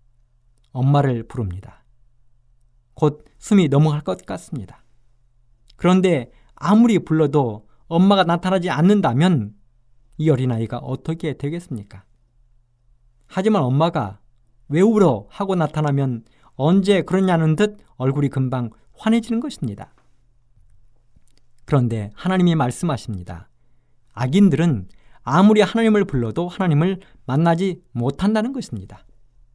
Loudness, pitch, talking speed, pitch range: -19 LUFS, 130 Hz, 260 characters per minute, 120-175 Hz